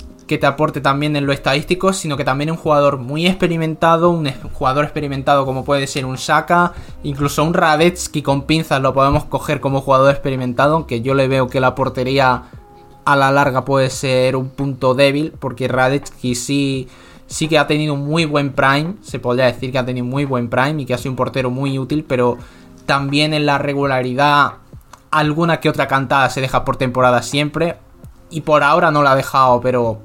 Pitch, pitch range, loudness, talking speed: 140 Hz, 130-150 Hz, -16 LUFS, 195 wpm